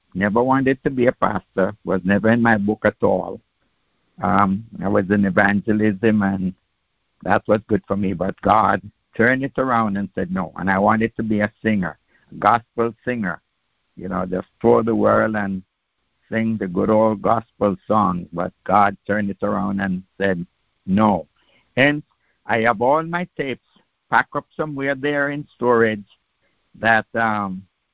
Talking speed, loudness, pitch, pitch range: 165 wpm, -20 LUFS, 105 Hz, 100-120 Hz